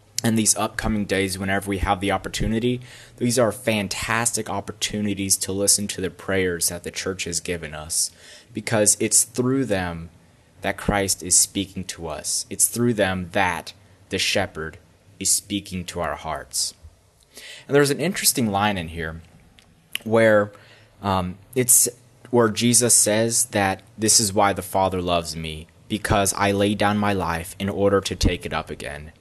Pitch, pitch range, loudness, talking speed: 100 Hz, 90-110 Hz, -21 LUFS, 160 wpm